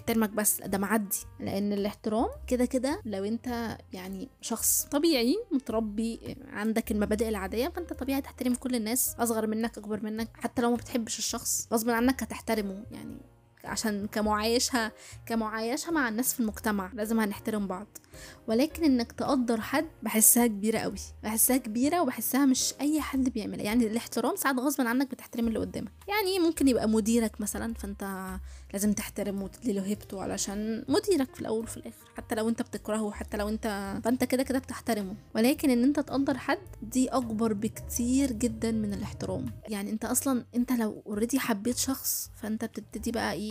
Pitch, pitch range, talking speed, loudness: 230 Hz, 215-255 Hz, 165 wpm, -29 LUFS